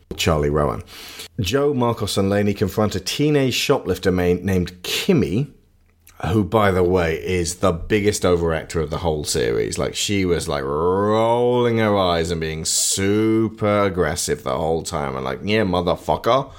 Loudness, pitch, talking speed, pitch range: -20 LUFS, 95 Hz, 155 wpm, 85-105 Hz